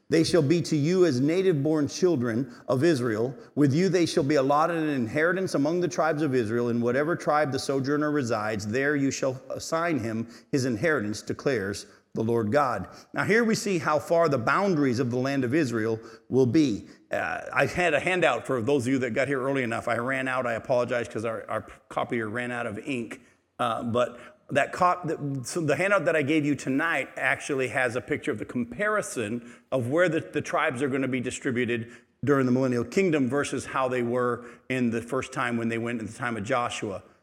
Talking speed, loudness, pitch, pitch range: 210 wpm, -26 LUFS, 135 Hz, 120-155 Hz